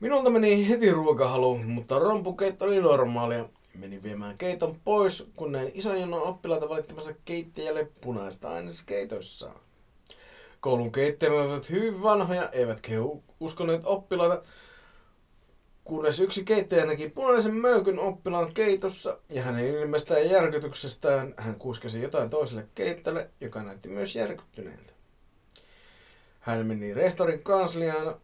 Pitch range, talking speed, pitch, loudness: 125-190 Hz, 120 wpm, 155 Hz, -27 LUFS